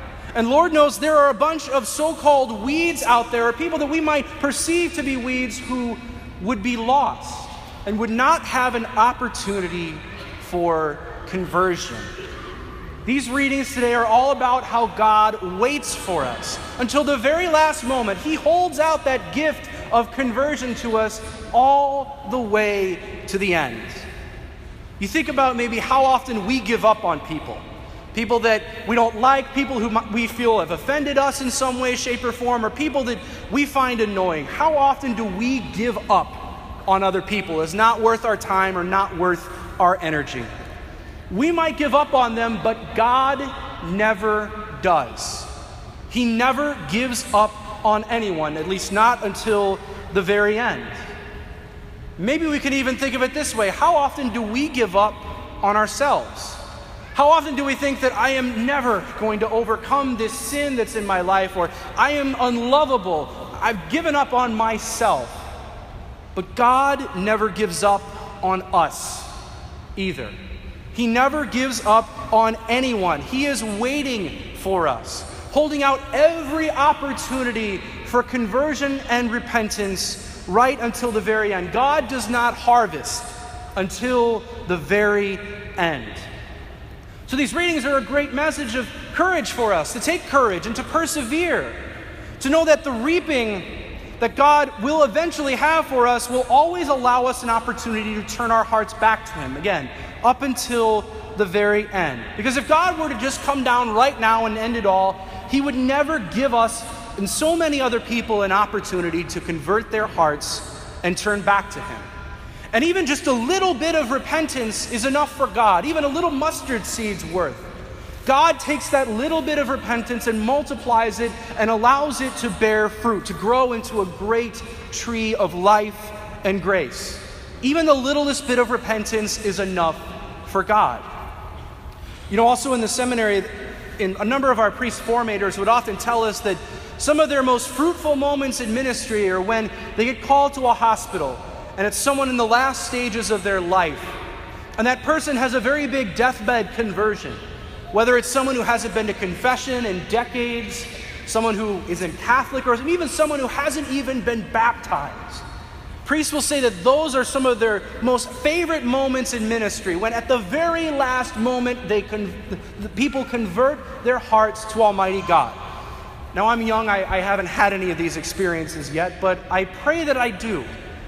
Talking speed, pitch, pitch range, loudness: 170 wpm, 235 Hz, 210-275 Hz, -20 LUFS